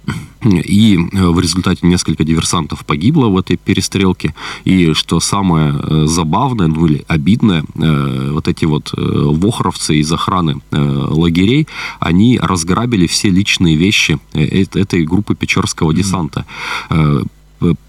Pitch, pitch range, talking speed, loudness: 85 Hz, 80-95 Hz, 105 wpm, -13 LUFS